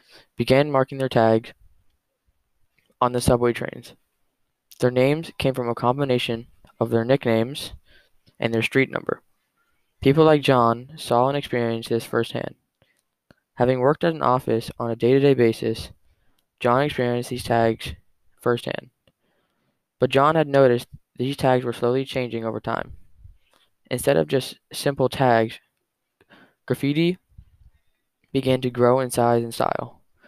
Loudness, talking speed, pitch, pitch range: -22 LUFS, 135 wpm, 120 Hz, 115-135 Hz